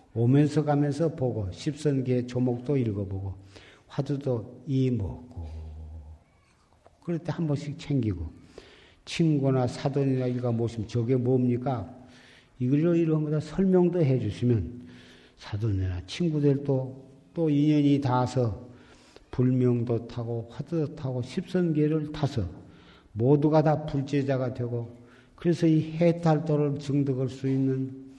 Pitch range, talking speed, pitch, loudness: 120-150 Hz, 255 characters per minute, 130 Hz, -27 LUFS